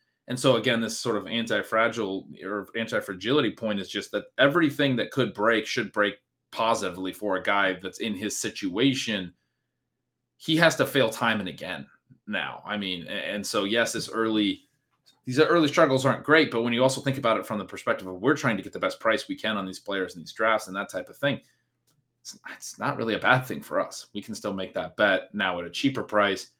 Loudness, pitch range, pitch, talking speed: -26 LUFS, 105-135 Hz, 115 Hz, 225 wpm